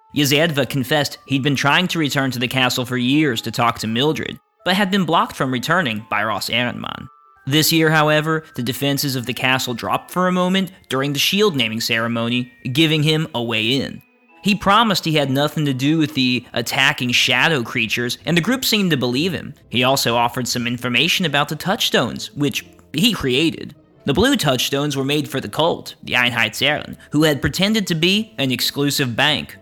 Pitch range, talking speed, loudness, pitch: 125-160 Hz, 190 wpm, -18 LUFS, 140 Hz